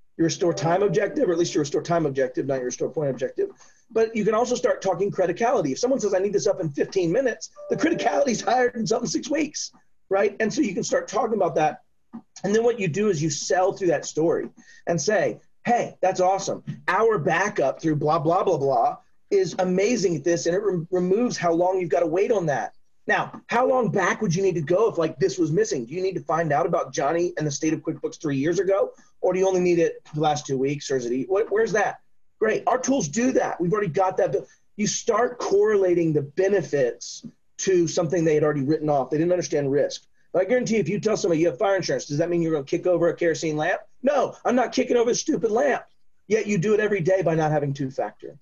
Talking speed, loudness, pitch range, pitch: 250 wpm, -23 LUFS, 165-225 Hz, 190 Hz